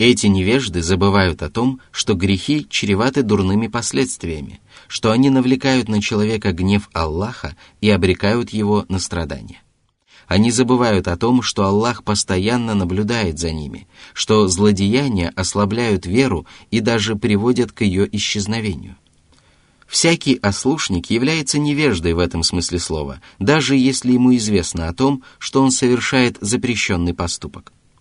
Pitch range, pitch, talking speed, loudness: 90-125 Hz, 105 Hz, 130 wpm, -17 LUFS